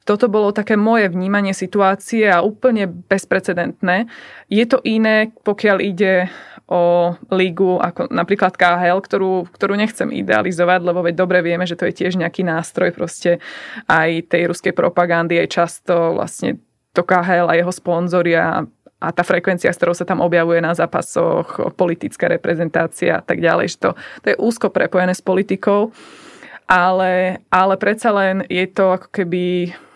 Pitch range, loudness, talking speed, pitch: 175-205 Hz, -17 LUFS, 155 wpm, 185 Hz